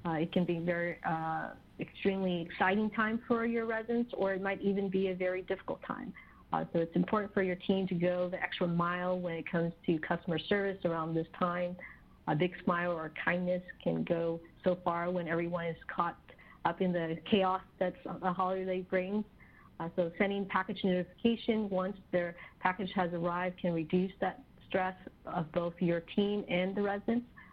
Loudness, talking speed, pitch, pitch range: -34 LUFS, 185 wpm, 180 Hz, 175-195 Hz